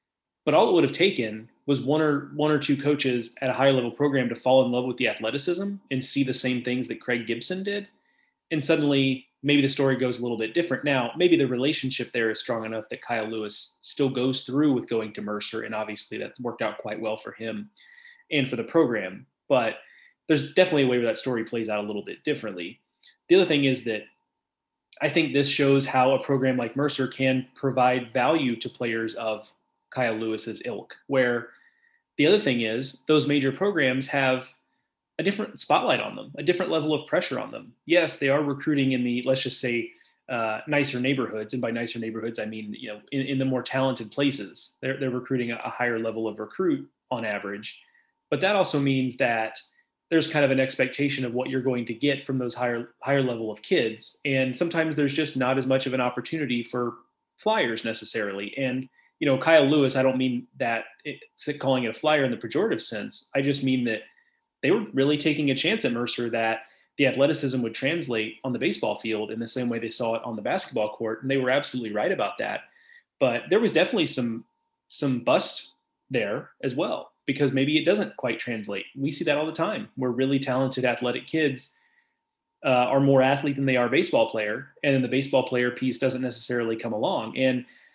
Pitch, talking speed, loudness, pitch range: 130 Hz, 210 wpm, -25 LUFS, 120-145 Hz